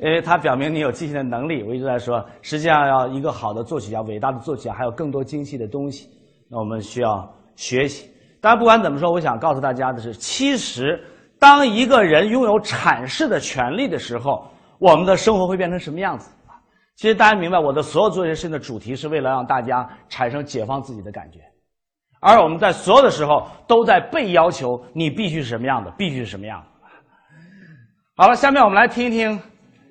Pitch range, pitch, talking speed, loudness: 125-185 Hz, 150 Hz, 325 characters per minute, -18 LUFS